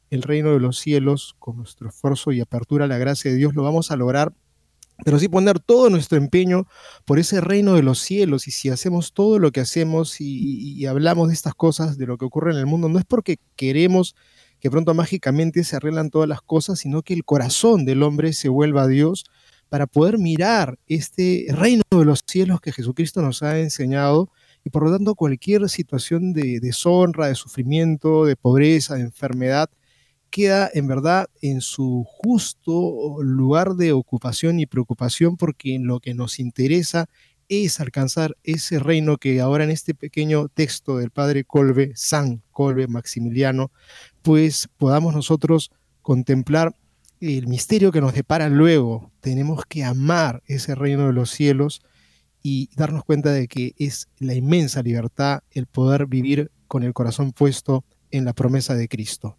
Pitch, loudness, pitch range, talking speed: 145 Hz, -20 LUFS, 130-165 Hz, 175 wpm